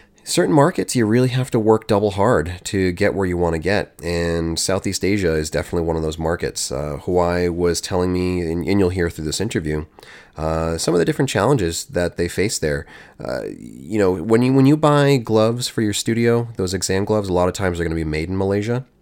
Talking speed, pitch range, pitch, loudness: 225 wpm, 85-110 Hz, 90 Hz, -19 LUFS